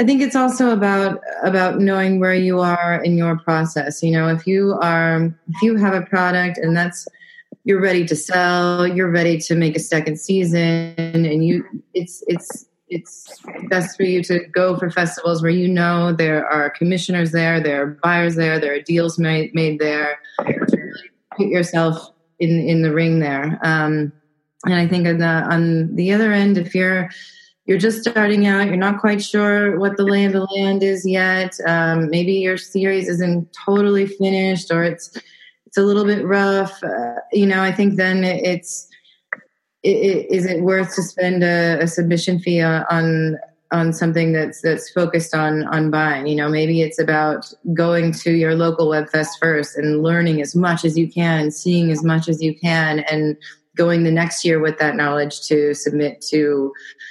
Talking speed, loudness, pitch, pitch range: 185 wpm, -18 LUFS, 170 Hz, 160-190 Hz